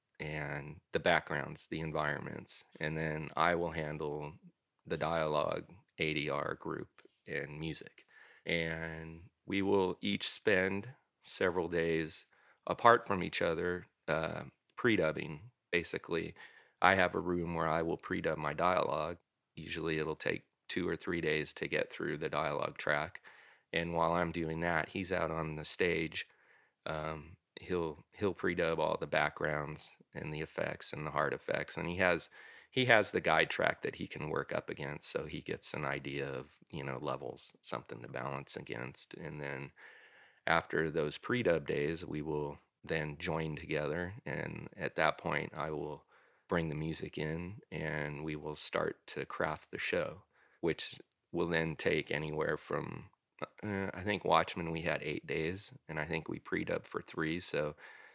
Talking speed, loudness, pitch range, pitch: 160 wpm, -36 LUFS, 75-85 Hz, 80 Hz